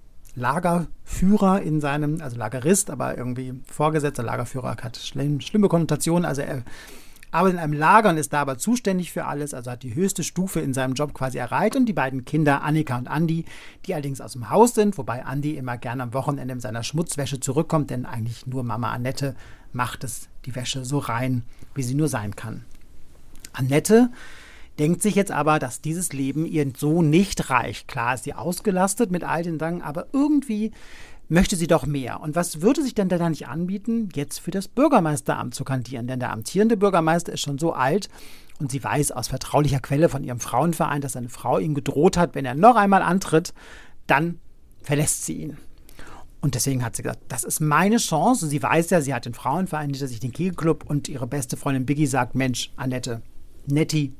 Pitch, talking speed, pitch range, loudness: 145 Hz, 195 wpm, 130-170 Hz, -23 LUFS